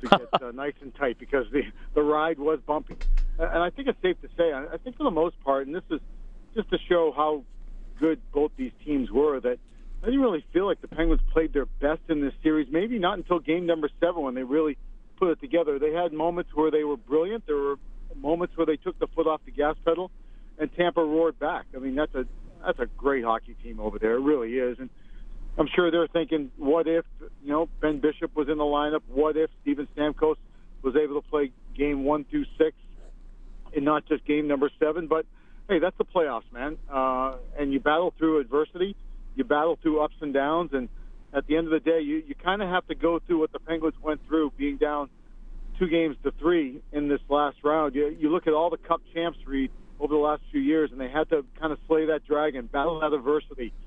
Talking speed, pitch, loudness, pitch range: 230 wpm, 155 Hz, -27 LUFS, 145-165 Hz